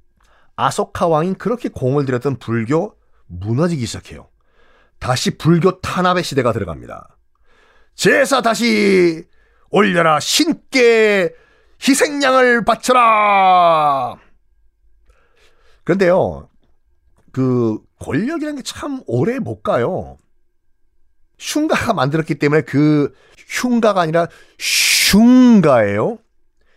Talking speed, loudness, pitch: 205 characters per minute, -15 LUFS, 180 Hz